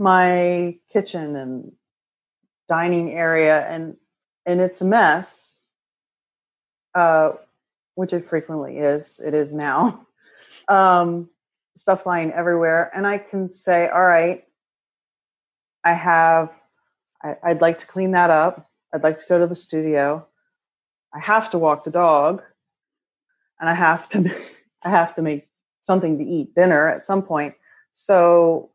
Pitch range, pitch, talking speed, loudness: 160-185 Hz, 170 Hz, 140 wpm, -19 LUFS